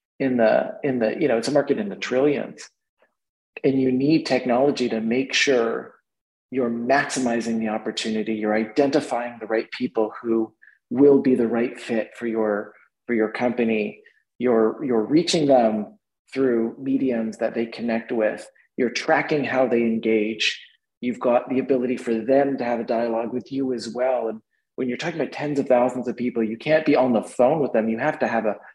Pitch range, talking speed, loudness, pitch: 110-130 Hz, 190 wpm, -22 LUFS, 120 Hz